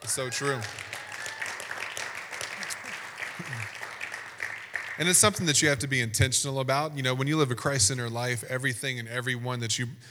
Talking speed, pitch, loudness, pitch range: 150 wpm, 130 Hz, -28 LUFS, 120-140 Hz